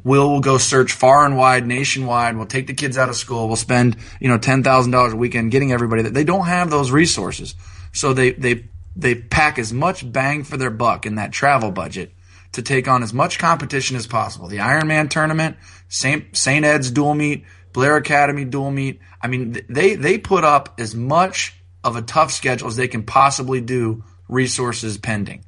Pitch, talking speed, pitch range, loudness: 130 Hz, 200 wpm, 115-140 Hz, -17 LUFS